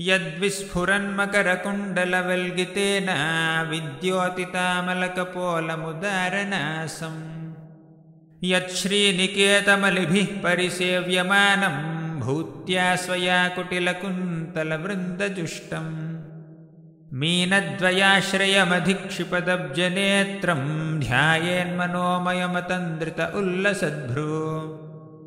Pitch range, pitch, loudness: 160-190 Hz, 180 Hz, -23 LUFS